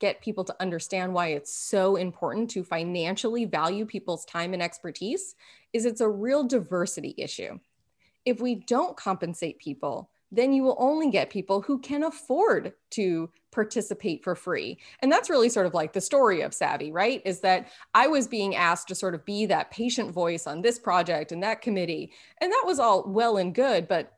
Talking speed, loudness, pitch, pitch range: 190 wpm, -27 LUFS, 195 Hz, 180-235 Hz